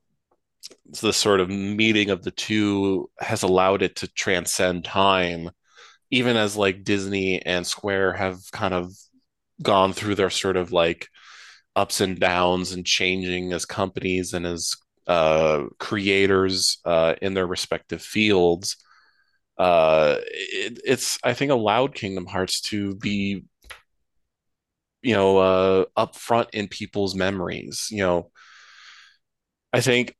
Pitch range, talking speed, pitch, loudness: 90-105 Hz, 130 wpm, 95 Hz, -22 LUFS